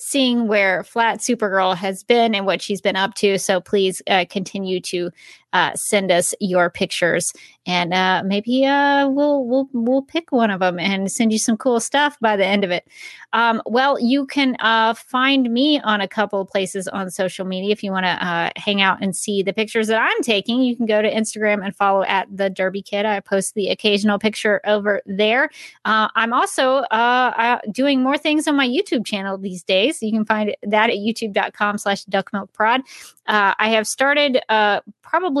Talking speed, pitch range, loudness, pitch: 205 wpm, 195-240 Hz, -19 LUFS, 210 Hz